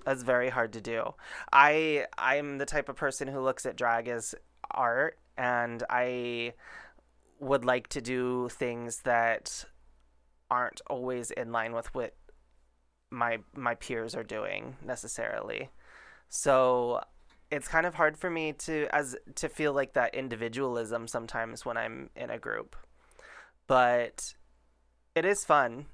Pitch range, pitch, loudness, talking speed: 115-140 Hz, 125 Hz, -31 LUFS, 140 wpm